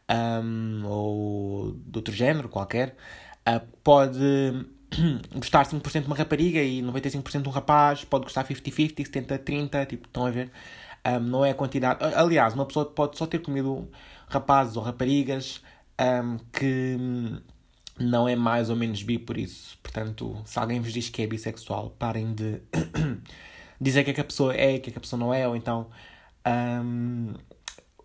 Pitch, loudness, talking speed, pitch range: 125 Hz, -27 LUFS, 170 wpm, 115-140 Hz